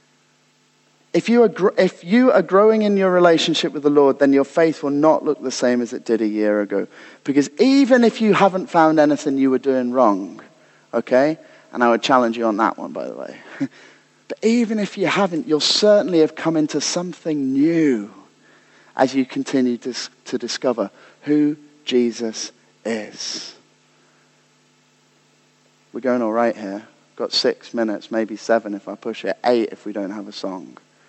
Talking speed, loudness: 180 wpm, -19 LUFS